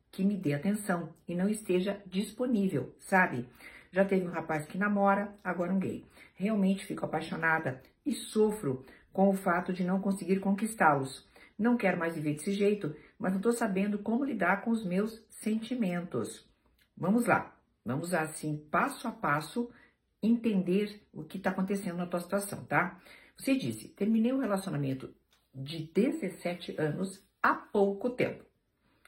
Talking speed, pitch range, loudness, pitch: 150 wpm, 175-210 Hz, -32 LUFS, 195 Hz